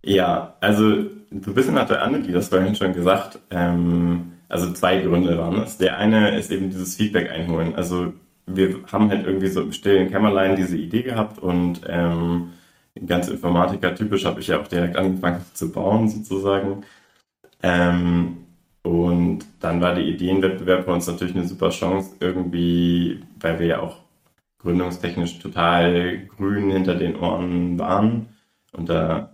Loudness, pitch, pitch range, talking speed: -21 LUFS, 90 Hz, 85-95 Hz, 160 wpm